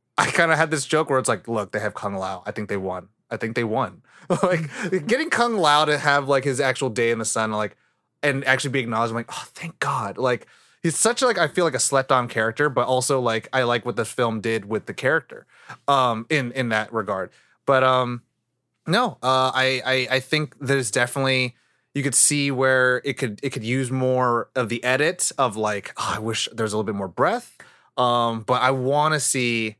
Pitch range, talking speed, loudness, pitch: 115-140 Hz, 230 wpm, -22 LUFS, 130 Hz